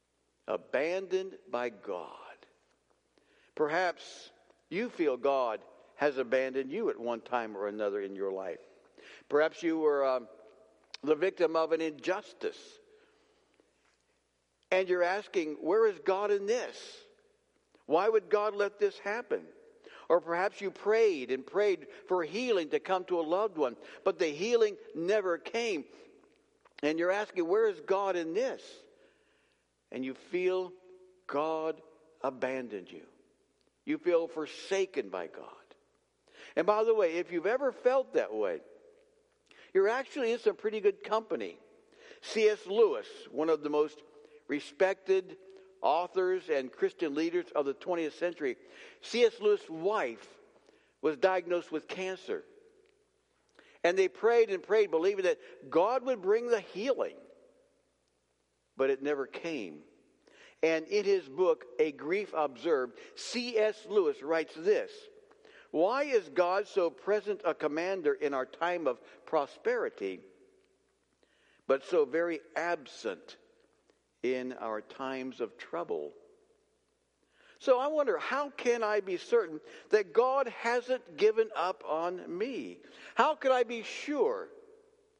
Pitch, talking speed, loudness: 355 Hz, 130 wpm, -32 LUFS